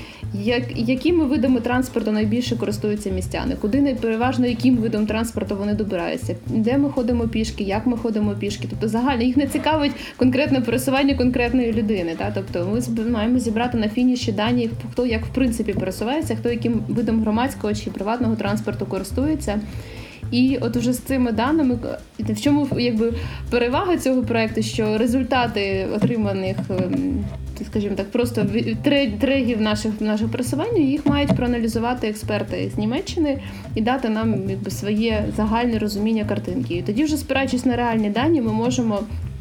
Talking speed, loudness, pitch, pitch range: 145 wpm, -21 LUFS, 235 Hz, 215-260 Hz